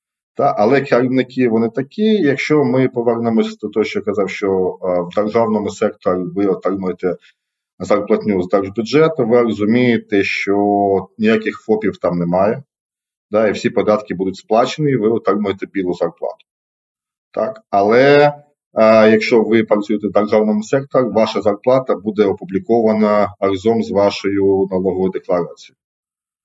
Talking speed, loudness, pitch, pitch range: 125 wpm, -16 LUFS, 110 Hz, 100-120 Hz